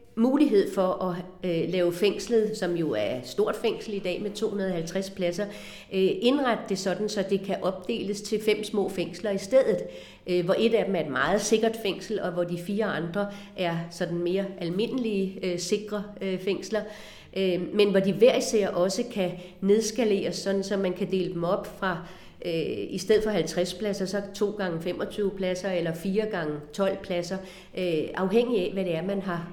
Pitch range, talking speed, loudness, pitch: 180-210 Hz, 190 wpm, -27 LUFS, 195 Hz